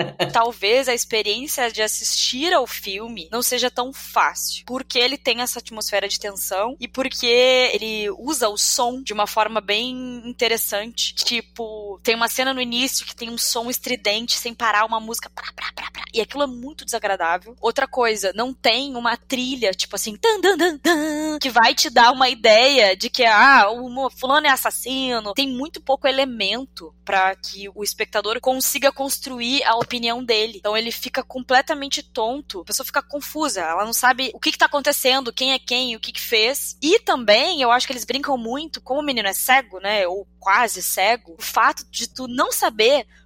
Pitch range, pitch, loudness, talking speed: 220-265 Hz, 245 Hz, -19 LUFS, 190 wpm